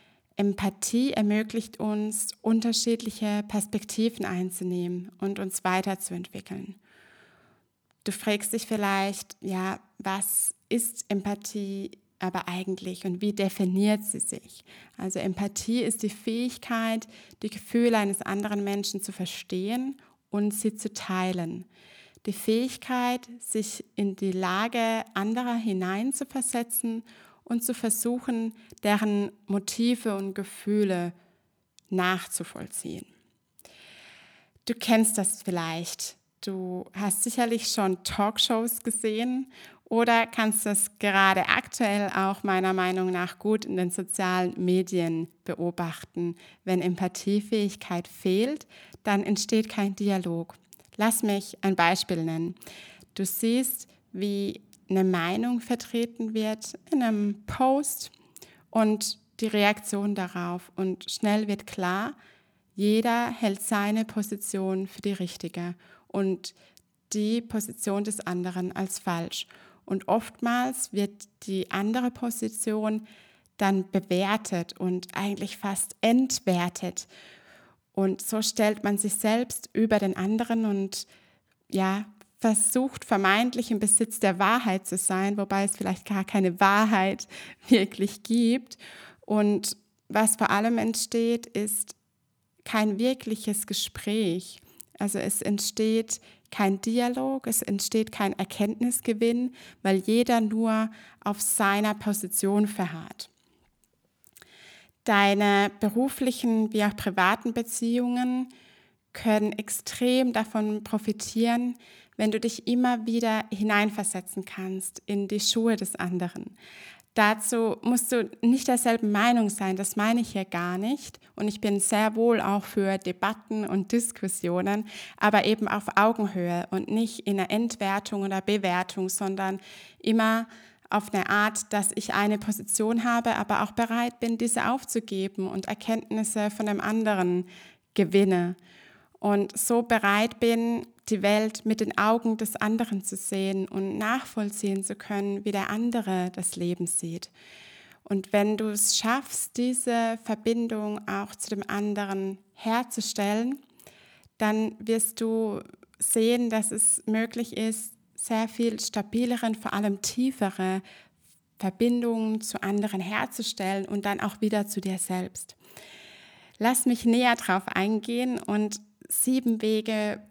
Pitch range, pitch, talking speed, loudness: 195-225 Hz, 210 Hz, 120 wpm, -27 LUFS